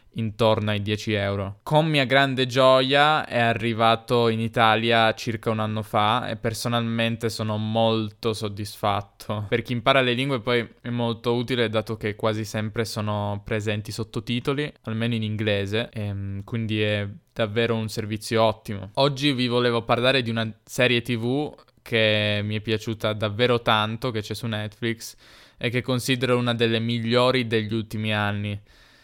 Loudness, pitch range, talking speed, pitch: -23 LUFS, 110-120 Hz, 150 wpm, 115 Hz